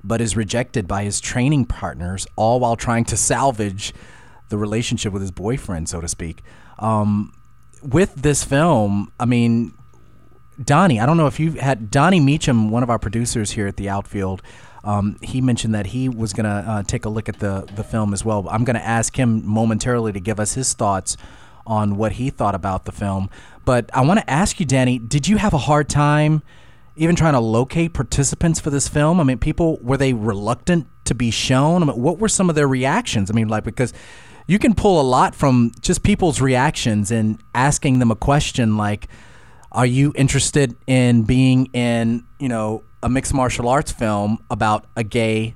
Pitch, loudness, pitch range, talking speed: 115 Hz, -19 LUFS, 105-135 Hz, 200 wpm